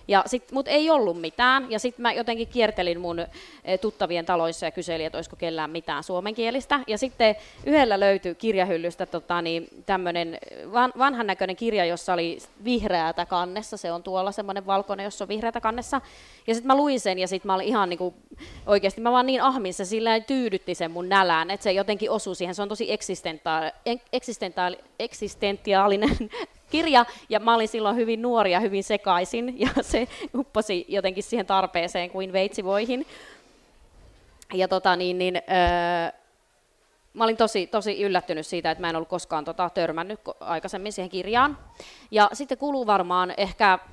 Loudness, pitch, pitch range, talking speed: -25 LUFS, 200 Hz, 180-230 Hz, 165 wpm